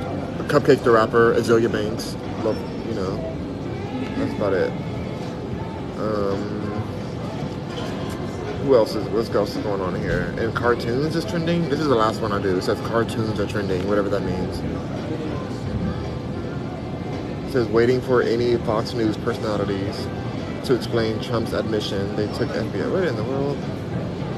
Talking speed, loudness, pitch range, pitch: 150 wpm, -23 LUFS, 100-120 Hz, 110 Hz